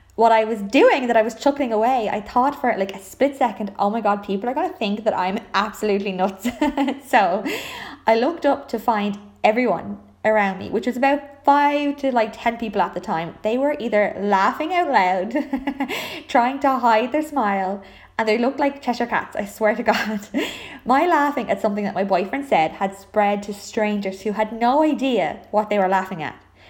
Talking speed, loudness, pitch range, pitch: 200 wpm, -21 LUFS, 205-270 Hz, 225 Hz